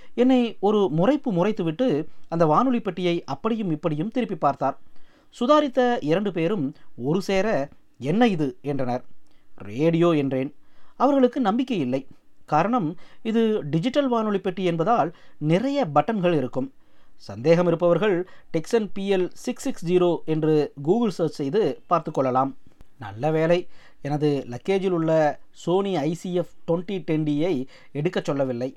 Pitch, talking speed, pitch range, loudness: 170 Hz, 120 wpm, 150-205 Hz, -23 LUFS